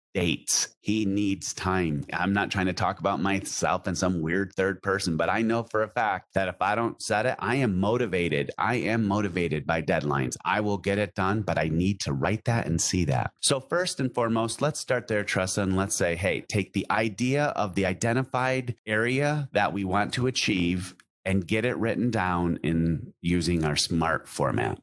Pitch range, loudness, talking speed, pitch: 90-115 Hz, -26 LUFS, 205 wpm, 100 Hz